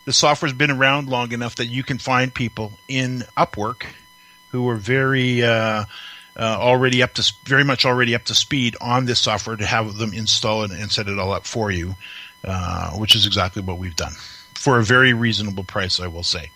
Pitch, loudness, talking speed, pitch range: 115 Hz, -19 LUFS, 205 wpm, 105-125 Hz